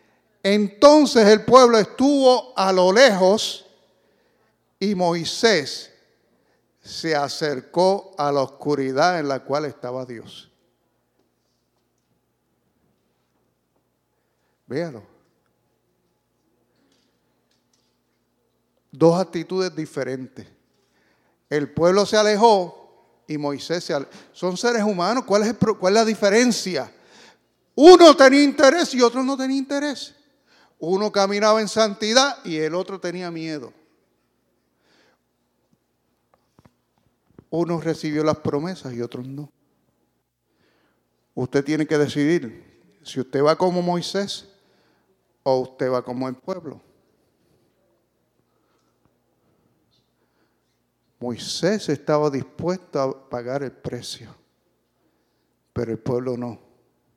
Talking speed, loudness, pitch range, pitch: 95 wpm, -19 LUFS, 135-210 Hz, 170 Hz